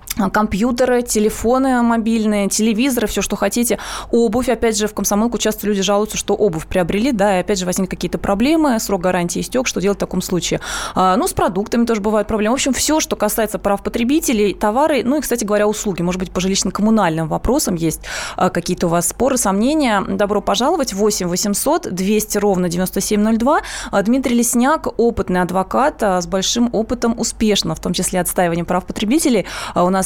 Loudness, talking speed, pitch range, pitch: -17 LUFS, 170 wpm, 190-235 Hz, 210 Hz